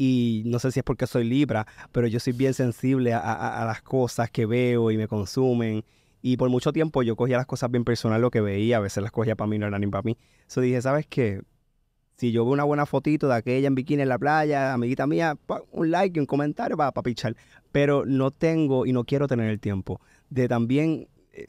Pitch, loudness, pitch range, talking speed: 125 Hz, -25 LUFS, 115-140 Hz, 235 wpm